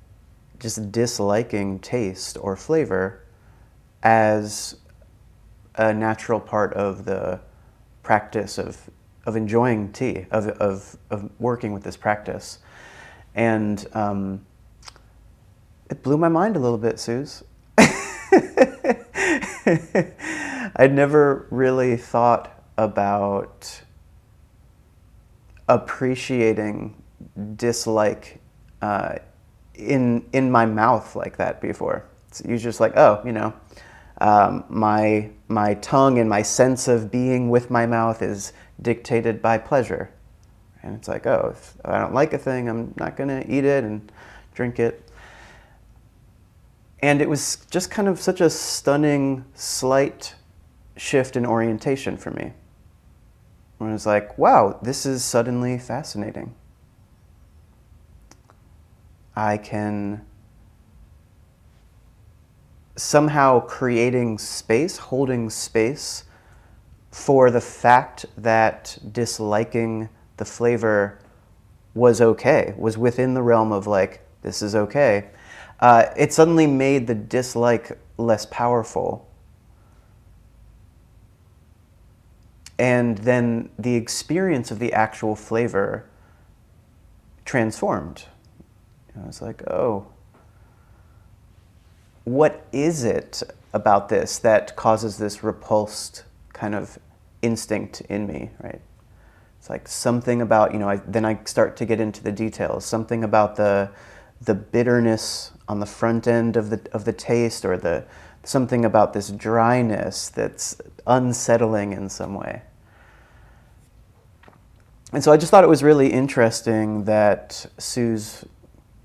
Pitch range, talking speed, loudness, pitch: 100-120 Hz, 115 wpm, -21 LUFS, 110 Hz